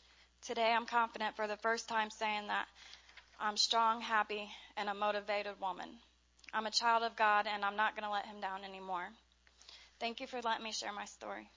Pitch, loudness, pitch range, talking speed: 215 Hz, -36 LUFS, 205-225 Hz, 195 wpm